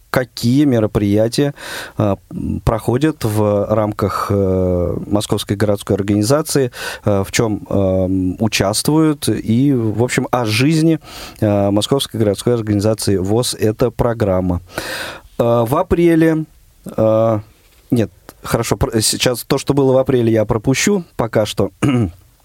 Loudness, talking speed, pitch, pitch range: -16 LUFS, 120 wpm, 110 Hz, 105-135 Hz